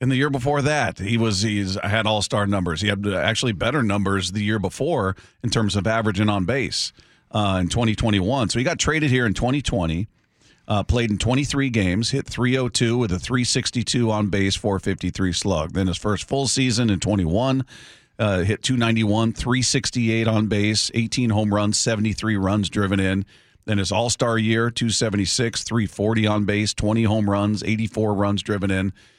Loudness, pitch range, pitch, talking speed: -21 LUFS, 100-120 Hz, 110 Hz, 175 wpm